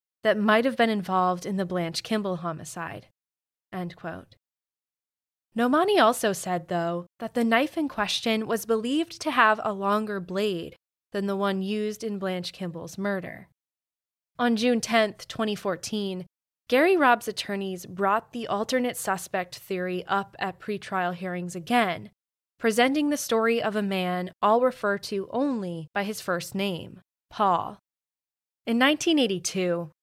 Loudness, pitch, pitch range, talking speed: -26 LUFS, 200 Hz, 180-230 Hz, 140 wpm